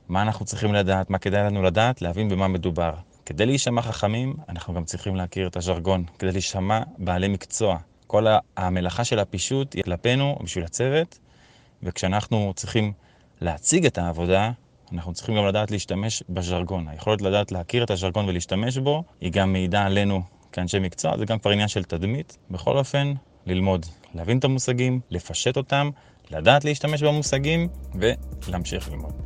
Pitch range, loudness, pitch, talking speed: 90-120 Hz, -24 LUFS, 100 Hz, 155 wpm